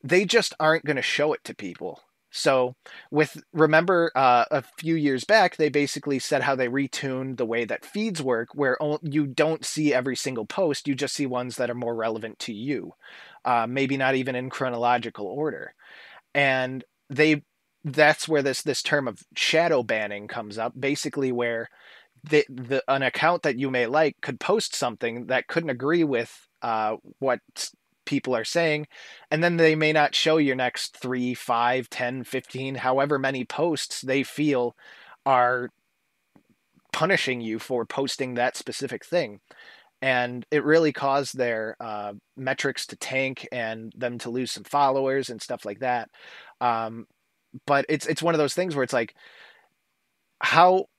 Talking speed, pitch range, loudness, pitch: 165 wpm, 125-150 Hz, -25 LUFS, 135 Hz